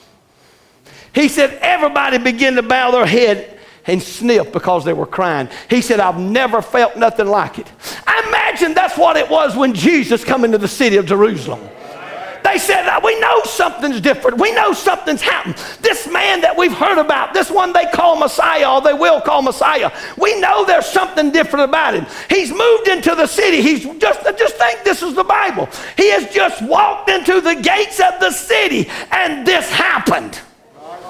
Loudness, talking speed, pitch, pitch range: -13 LUFS, 185 wpm, 310 Hz, 245-370 Hz